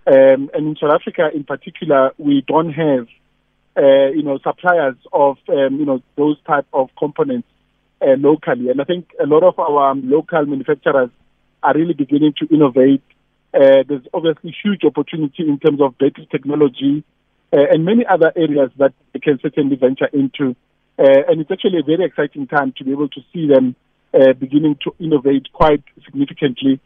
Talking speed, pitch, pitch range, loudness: 175 wpm, 150 Hz, 135-160 Hz, -15 LUFS